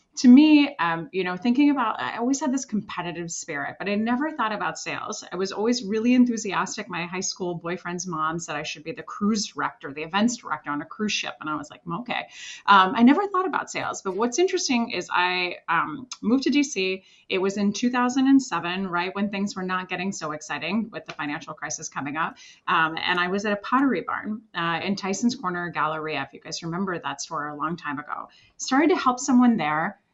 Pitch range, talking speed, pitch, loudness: 165-240 Hz, 215 wpm, 190 Hz, -24 LUFS